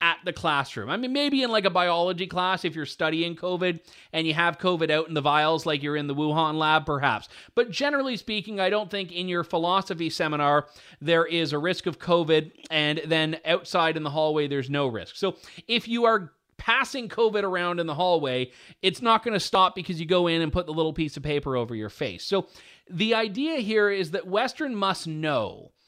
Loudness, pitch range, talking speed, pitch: -25 LUFS, 155-195 Hz, 215 wpm, 170 Hz